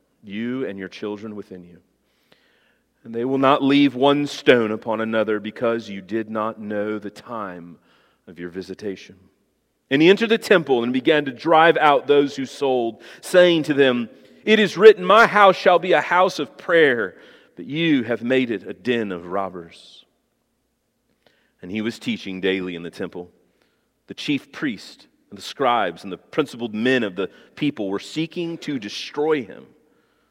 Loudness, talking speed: -19 LUFS, 170 wpm